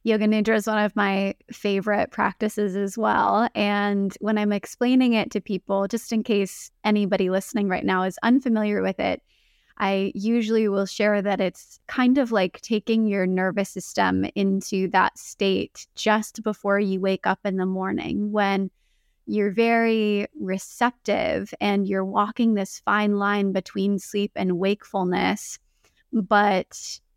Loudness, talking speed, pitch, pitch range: -23 LUFS, 150 wpm, 205 Hz, 195-215 Hz